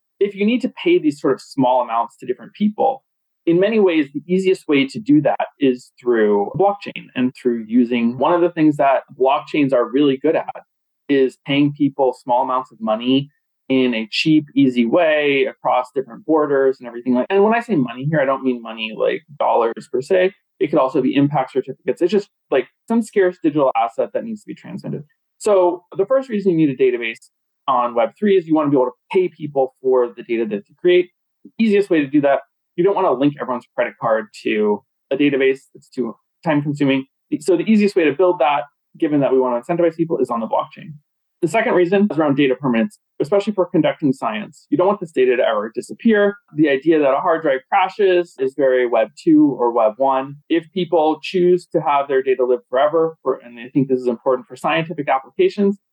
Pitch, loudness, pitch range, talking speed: 155 Hz, -18 LUFS, 130-195 Hz, 215 wpm